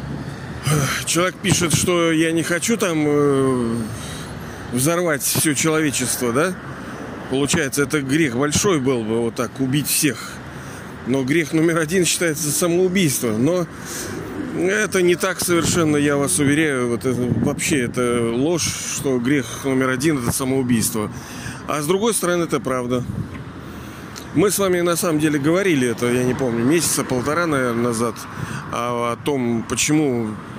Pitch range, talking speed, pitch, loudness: 125-165 Hz, 140 wpm, 145 Hz, -19 LUFS